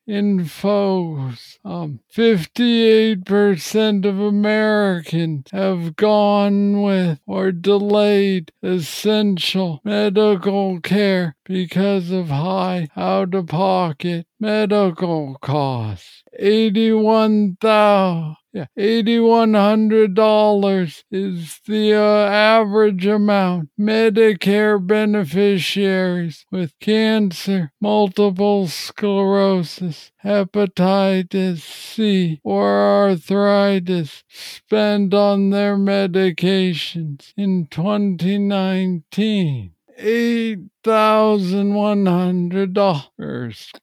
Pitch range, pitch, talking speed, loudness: 180-210 Hz, 195 Hz, 60 wpm, -17 LUFS